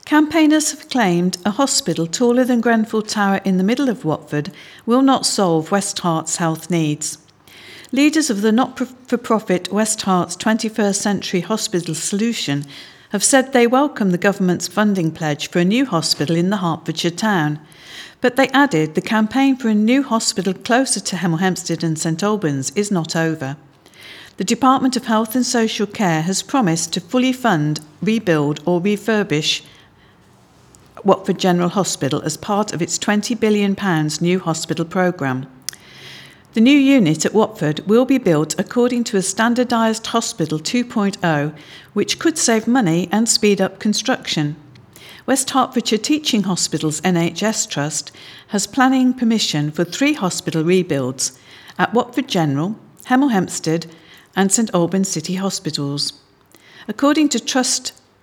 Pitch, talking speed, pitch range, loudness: 195 Hz, 145 wpm, 165-235 Hz, -18 LUFS